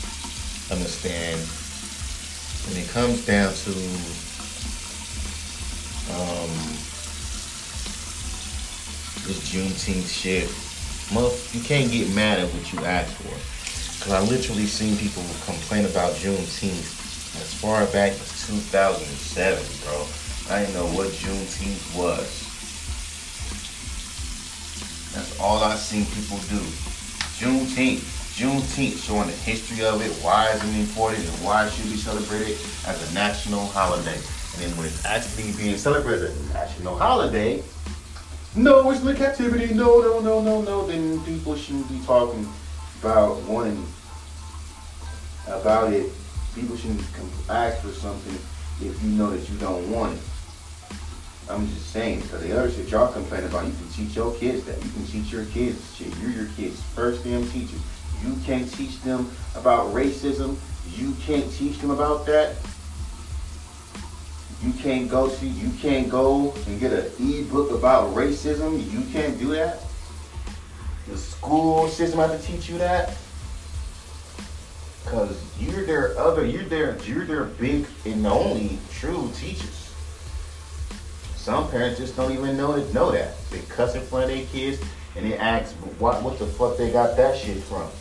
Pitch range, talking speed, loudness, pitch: 75-110 Hz, 150 wpm, -25 LUFS, 85 Hz